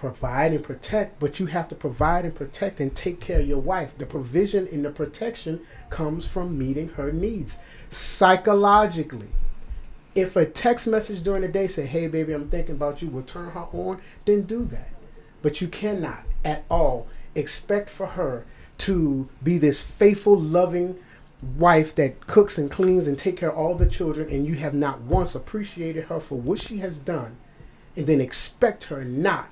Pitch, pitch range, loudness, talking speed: 160 Hz, 145-185 Hz, -24 LUFS, 185 wpm